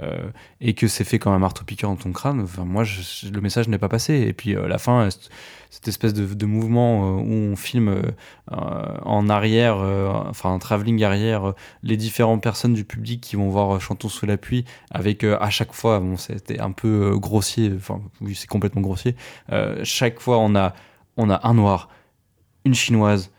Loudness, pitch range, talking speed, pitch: -22 LUFS, 100-115 Hz, 215 wpm, 105 Hz